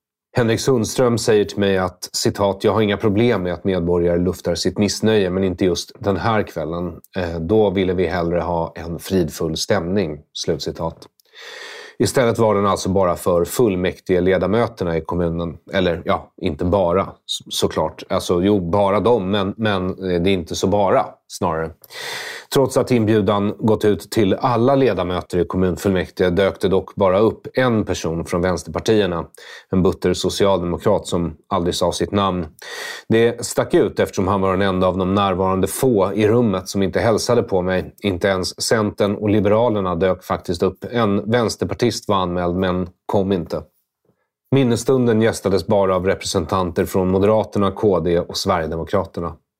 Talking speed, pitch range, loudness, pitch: 155 wpm, 90-105 Hz, -19 LUFS, 95 Hz